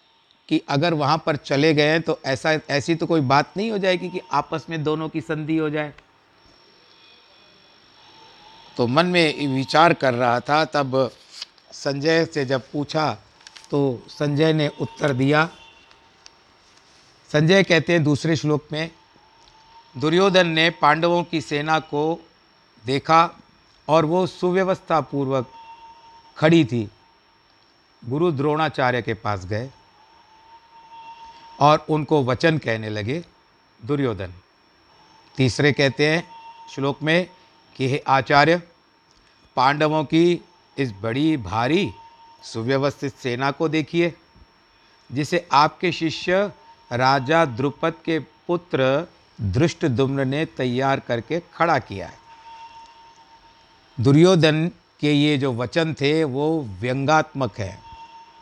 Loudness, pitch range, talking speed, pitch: -21 LUFS, 135-175 Hz, 115 wpm, 155 Hz